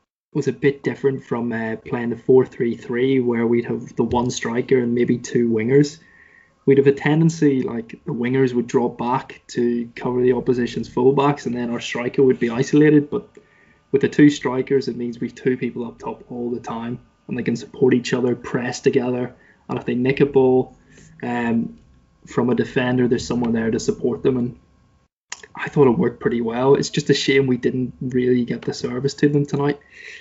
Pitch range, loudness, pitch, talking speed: 120-135 Hz, -20 LUFS, 125 Hz, 205 wpm